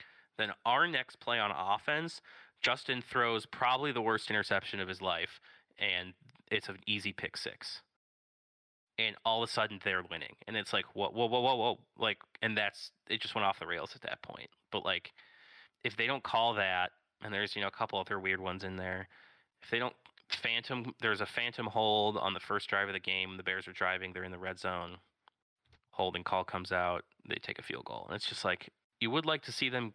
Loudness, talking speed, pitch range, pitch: -35 LUFS, 220 wpm, 95-115 Hz, 100 Hz